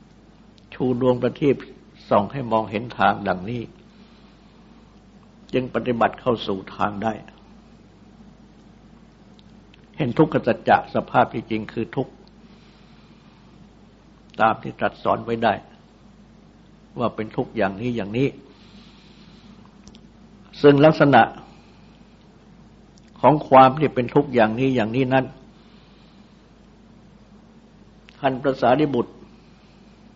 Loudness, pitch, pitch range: -21 LUFS, 125 Hz, 110-145 Hz